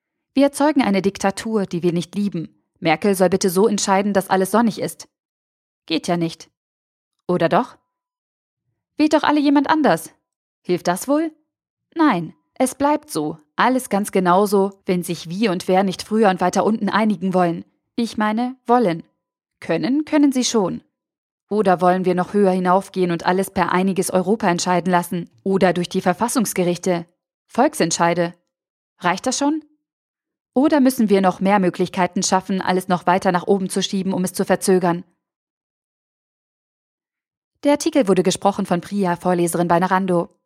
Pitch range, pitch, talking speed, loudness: 175-225 Hz, 190 Hz, 155 wpm, -19 LUFS